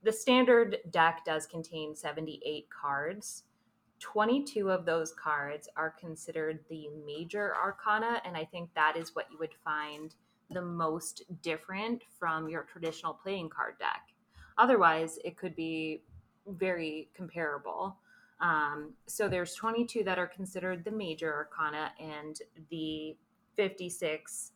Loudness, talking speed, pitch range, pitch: -33 LUFS, 130 wpm, 155-195 Hz, 165 Hz